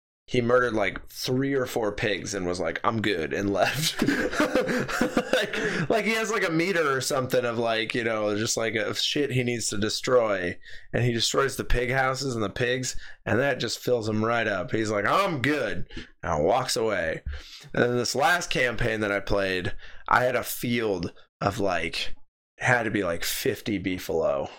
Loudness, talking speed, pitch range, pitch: -26 LUFS, 190 wpm, 105-130 Hz, 120 Hz